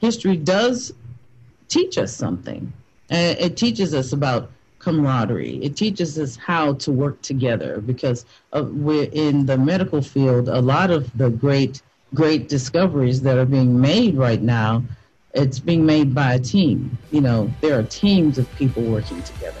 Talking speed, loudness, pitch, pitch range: 155 wpm, -19 LUFS, 135 Hz, 125-155 Hz